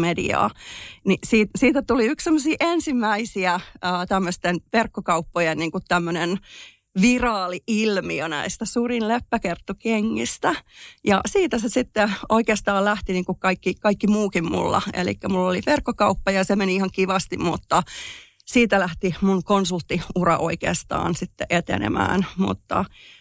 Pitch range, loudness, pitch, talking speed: 180-225 Hz, -22 LUFS, 195 Hz, 115 wpm